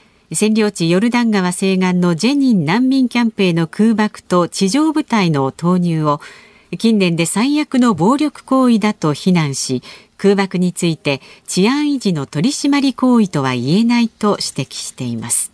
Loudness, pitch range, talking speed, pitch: -15 LUFS, 165-235 Hz, 315 characters per minute, 195 Hz